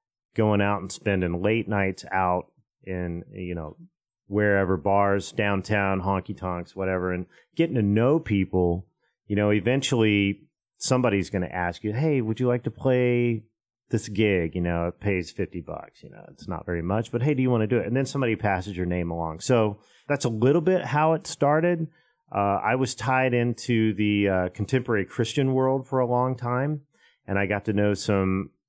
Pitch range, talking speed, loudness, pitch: 95-125 Hz, 190 wpm, -25 LUFS, 105 Hz